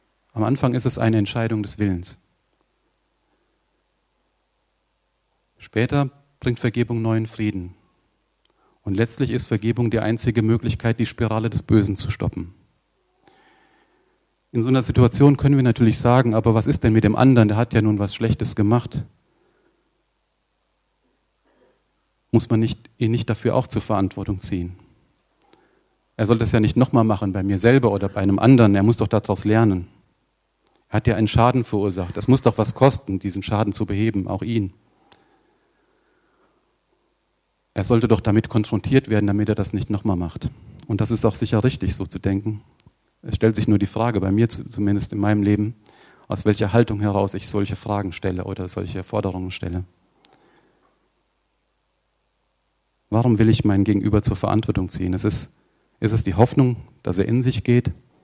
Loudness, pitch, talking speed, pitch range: -20 LUFS, 110 Hz, 165 wpm, 100-120 Hz